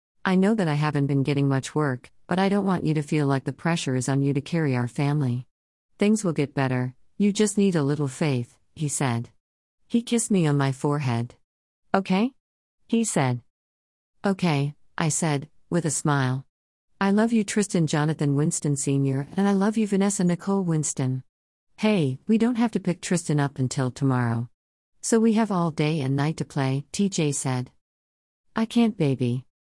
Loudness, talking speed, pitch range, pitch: -24 LUFS, 185 wpm, 130-190 Hz, 145 Hz